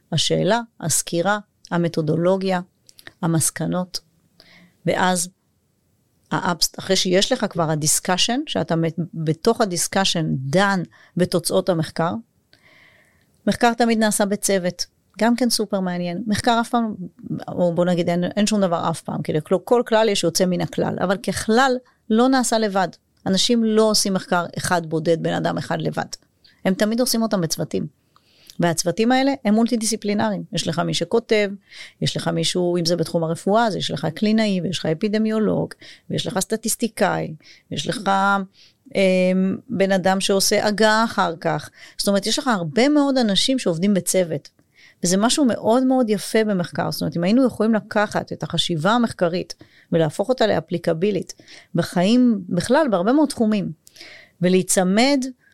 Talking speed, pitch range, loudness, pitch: 145 wpm, 175-220 Hz, -20 LUFS, 195 Hz